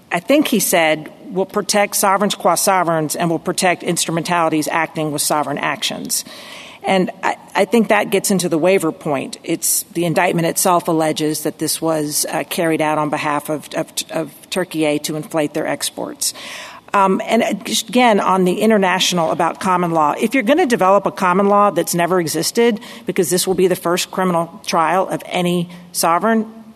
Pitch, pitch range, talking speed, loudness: 180 Hz, 165-205 Hz, 180 wpm, -17 LUFS